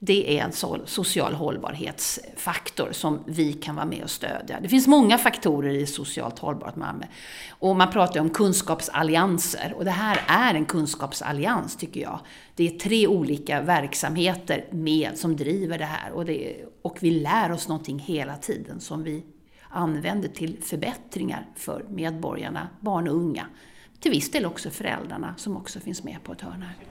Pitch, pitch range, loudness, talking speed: 165 Hz, 150-185 Hz, -25 LUFS, 165 wpm